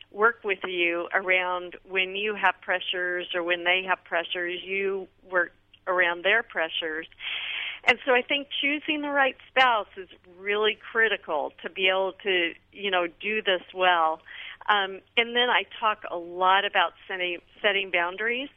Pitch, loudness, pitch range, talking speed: 190 Hz, -25 LUFS, 180-215 Hz, 160 wpm